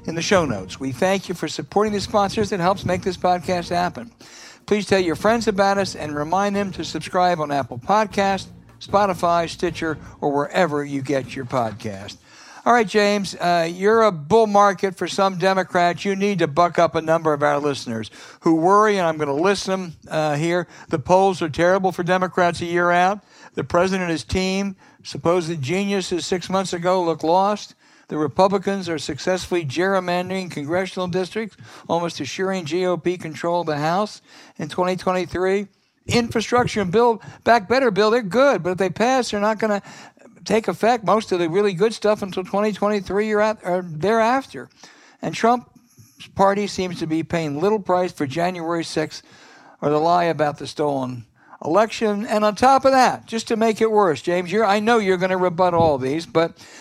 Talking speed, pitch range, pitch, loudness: 185 wpm, 165-205 Hz, 185 Hz, -20 LUFS